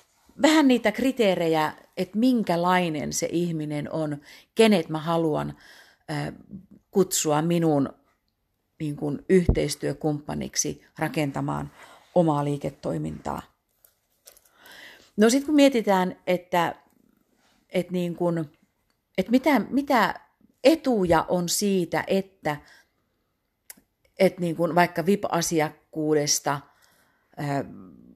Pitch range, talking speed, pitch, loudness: 150-195 Hz, 80 wpm, 170 Hz, -24 LUFS